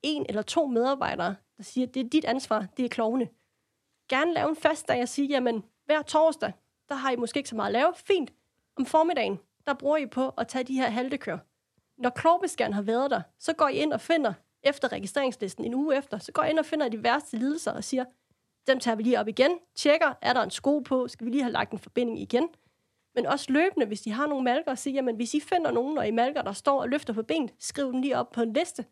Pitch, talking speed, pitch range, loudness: 260 Hz, 255 wpm, 235-295 Hz, -28 LUFS